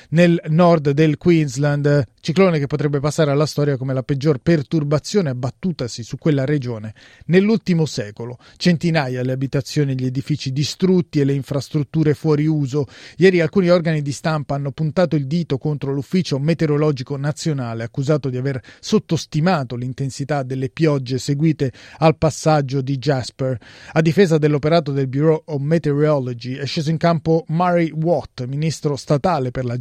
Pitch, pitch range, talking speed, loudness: 150 Hz, 135-160 Hz, 150 wpm, -19 LUFS